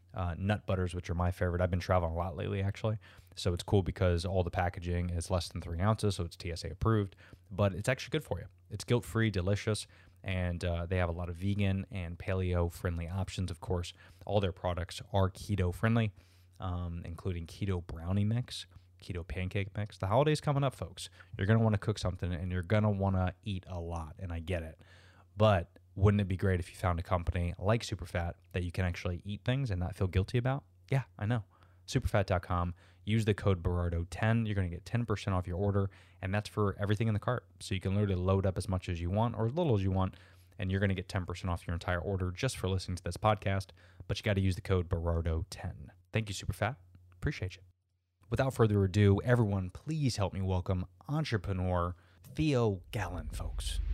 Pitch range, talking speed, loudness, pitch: 90-105 Hz, 220 wpm, -34 LUFS, 95 Hz